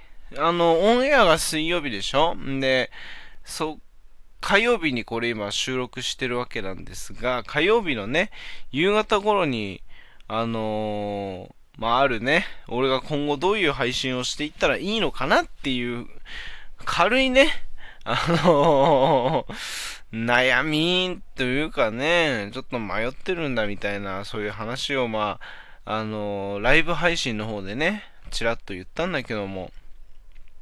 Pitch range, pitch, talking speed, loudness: 105-165 Hz, 125 Hz, 270 characters per minute, -23 LUFS